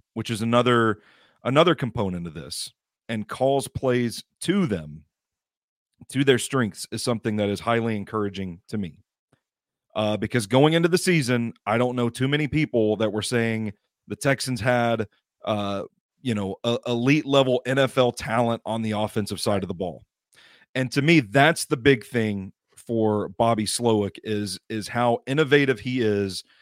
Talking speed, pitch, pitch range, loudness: 160 wpm, 115 Hz, 105-130 Hz, -24 LUFS